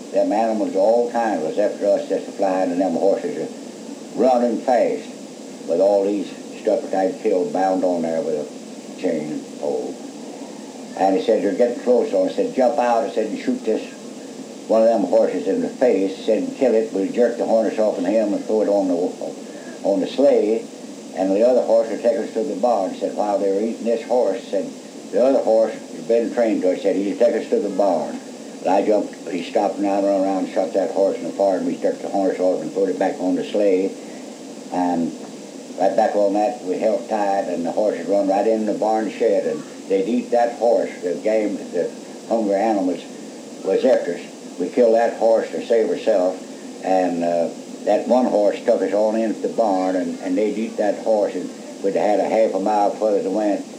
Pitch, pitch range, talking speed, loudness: 110 Hz, 95-120 Hz, 220 wpm, -20 LUFS